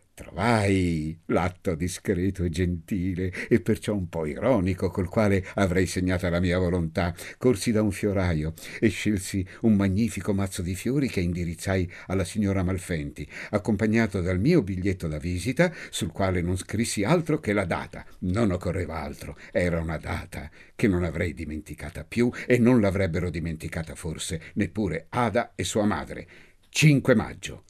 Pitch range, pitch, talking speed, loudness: 85-105 Hz, 95 Hz, 150 wpm, -26 LUFS